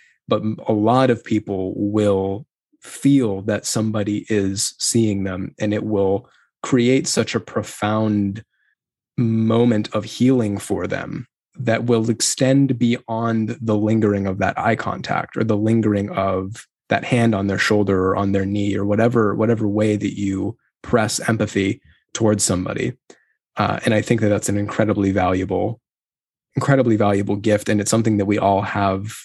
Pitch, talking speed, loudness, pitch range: 105 Hz, 155 wpm, -19 LUFS, 100-115 Hz